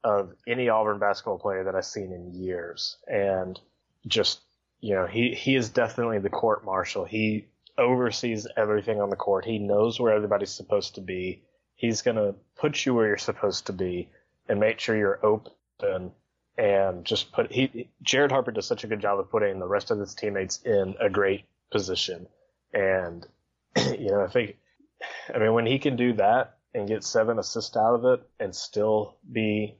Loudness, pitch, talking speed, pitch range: -26 LUFS, 110 Hz, 185 wpm, 100-125 Hz